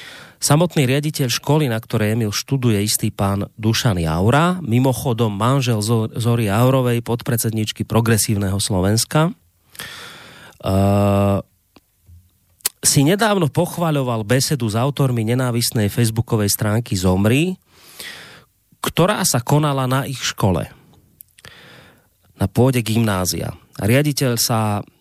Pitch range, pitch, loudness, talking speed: 105-135 Hz, 115 Hz, -18 LUFS, 100 wpm